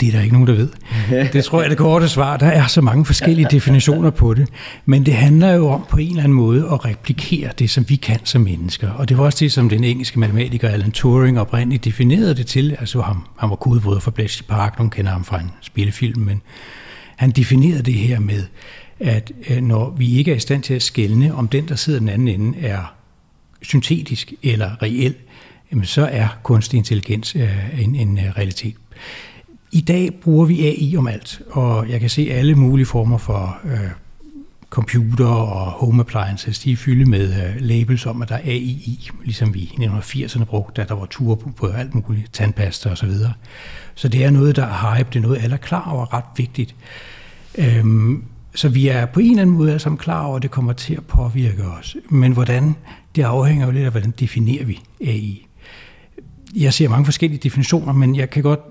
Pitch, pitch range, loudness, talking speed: 125 Hz, 110-140 Hz, -17 LUFS, 210 wpm